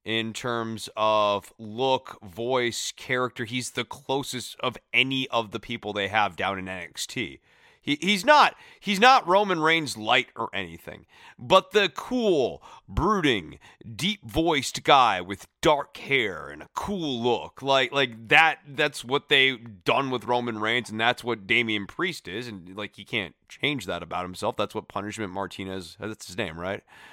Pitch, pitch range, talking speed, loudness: 120 Hz, 105-135 Hz, 165 wpm, -25 LUFS